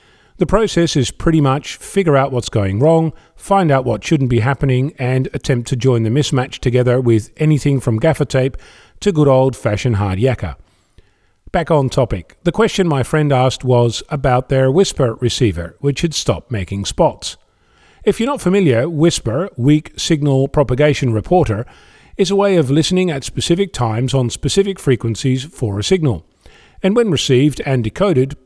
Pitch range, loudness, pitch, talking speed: 120-160 Hz, -16 LUFS, 135 Hz, 165 wpm